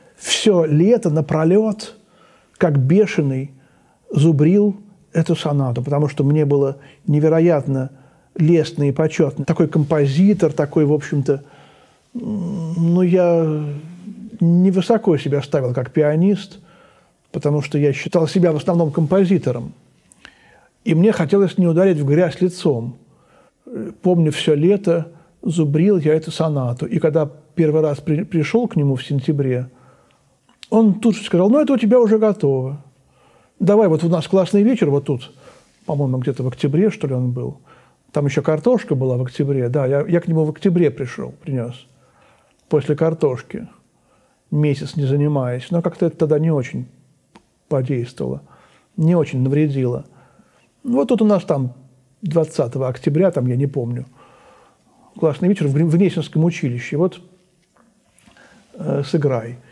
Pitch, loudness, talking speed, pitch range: 160 Hz, -18 LUFS, 140 wpm, 140-180 Hz